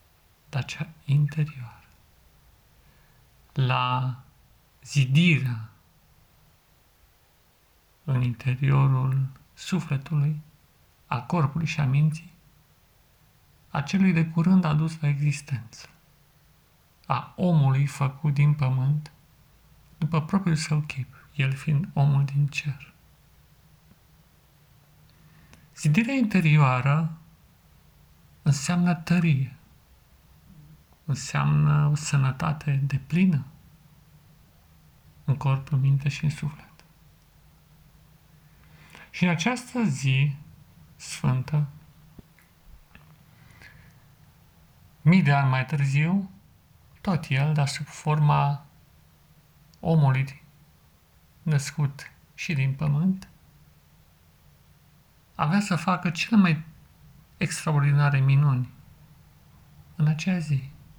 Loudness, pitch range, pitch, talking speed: -25 LUFS, 135-155 Hz, 145 Hz, 80 wpm